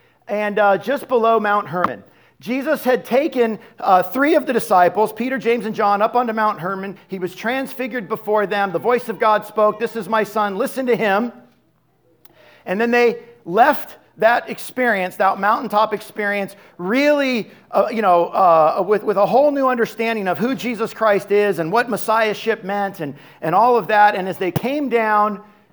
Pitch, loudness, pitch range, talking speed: 215 Hz, -18 LUFS, 200-235 Hz, 180 wpm